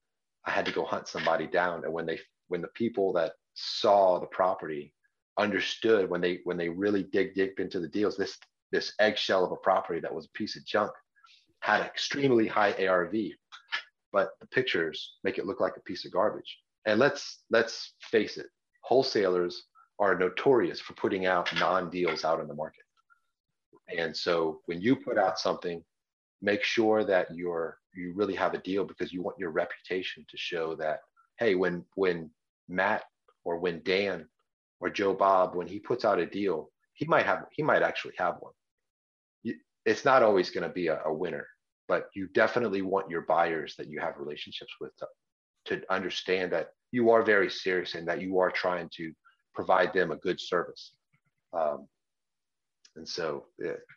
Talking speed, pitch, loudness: 180 wpm, 100 Hz, -29 LUFS